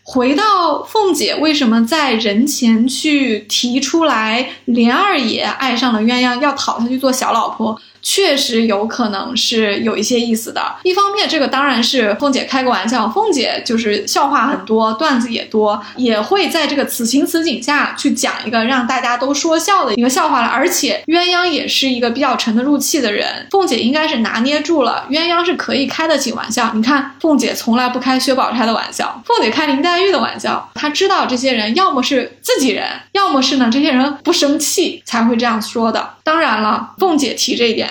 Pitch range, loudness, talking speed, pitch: 235-310 Hz, -14 LUFS, 300 characters per minute, 265 Hz